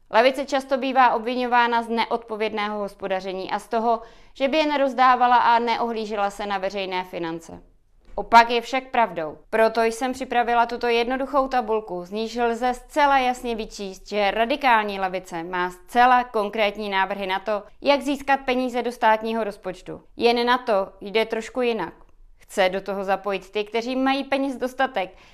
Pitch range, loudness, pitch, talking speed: 200-250 Hz, -22 LUFS, 225 Hz, 155 wpm